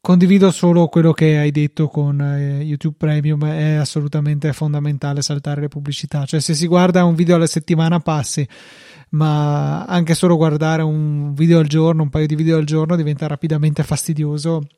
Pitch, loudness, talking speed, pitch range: 155 Hz, -16 LUFS, 170 wpm, 150-165 Hz